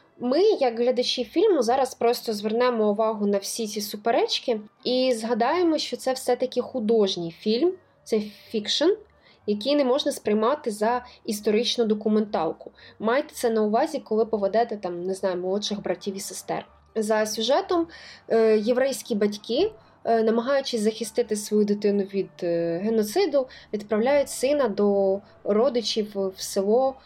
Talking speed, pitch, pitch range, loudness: 125 wpm, 225 Hz, 210-255 Hz, -24 LUFS